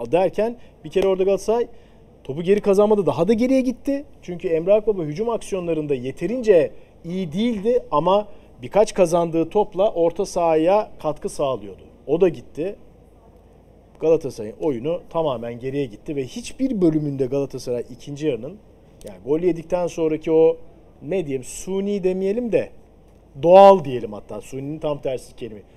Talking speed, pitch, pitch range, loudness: 135 wpm, 175 Hz, 150-210 Hz, -21 LUFS